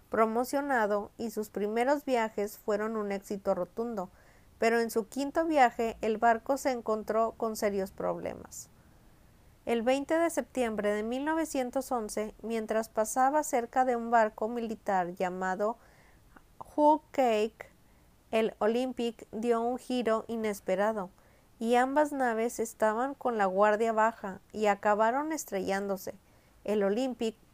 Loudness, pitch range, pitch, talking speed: -30 LUFS, 210-250 Hz, 225 Hz, 120 wpm